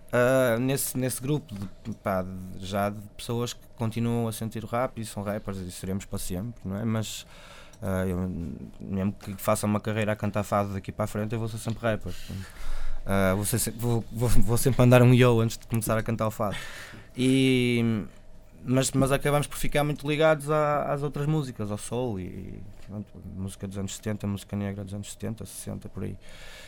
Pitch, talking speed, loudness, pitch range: 105 Hz, 200 wpm, -27 LUFS, 100-120 Hz